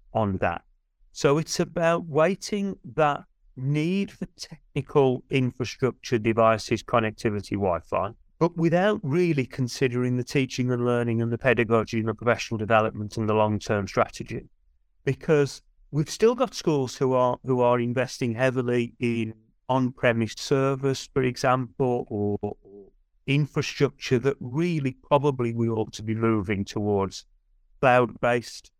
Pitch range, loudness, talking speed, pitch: 110-140 Hz, -25 LUFS, 135 wpm, 125 Hz